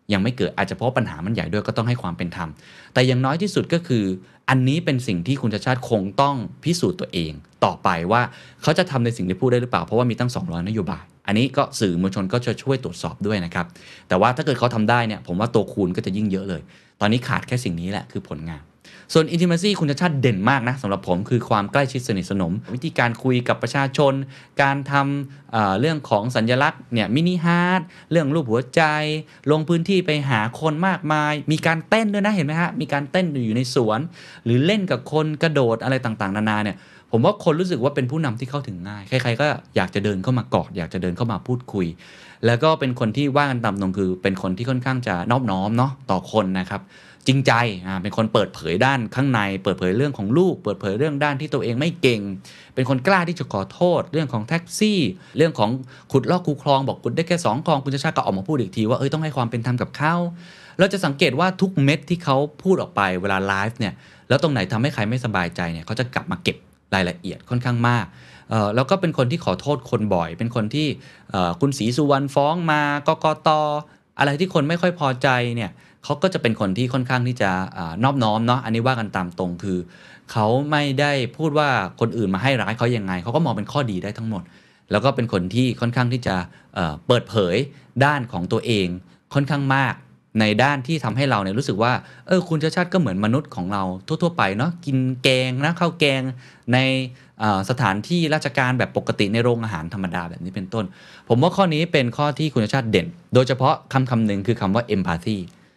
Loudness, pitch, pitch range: -21 LUFS, 125 Hz, 105-150 Hz